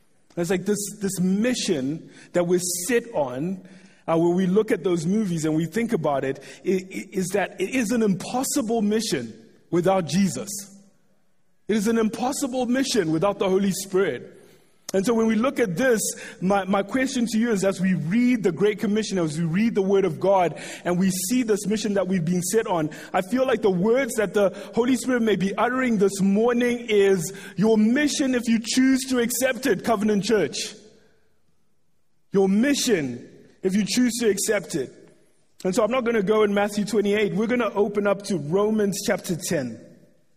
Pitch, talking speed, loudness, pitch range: 205 Hz, 195 wpm, -23 LUFS, 185-230 Hz